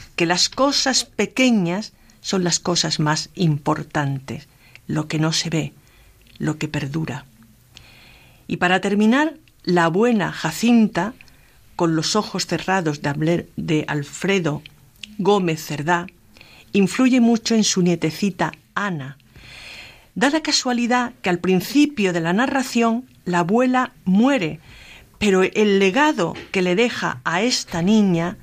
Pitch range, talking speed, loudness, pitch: 155-215 Hz, 120 wpm, -20 LUFS, 175 Hz